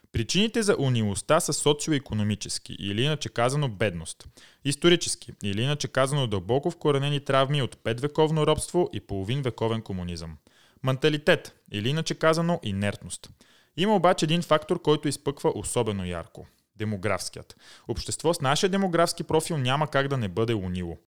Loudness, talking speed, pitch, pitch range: -26 LUFS, 135 wpm, 135 Hz, 110-155 Hz